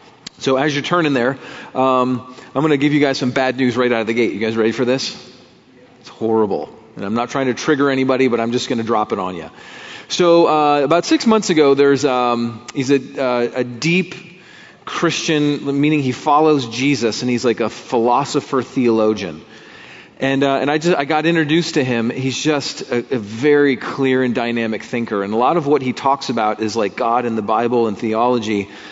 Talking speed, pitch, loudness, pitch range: 210 wpm, 130 Hz, -17 LUFS, 120-145 Hz